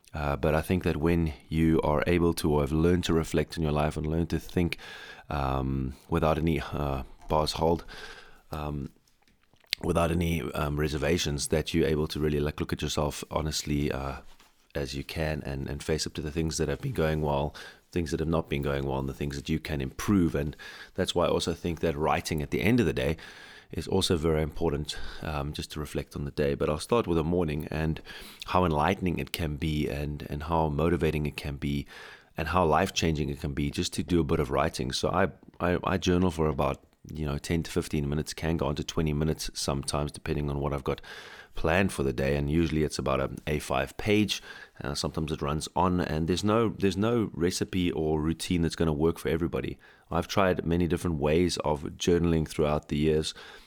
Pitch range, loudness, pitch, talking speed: 75-85 Hz, -29 LUFS, 80 Hz, 220 wpm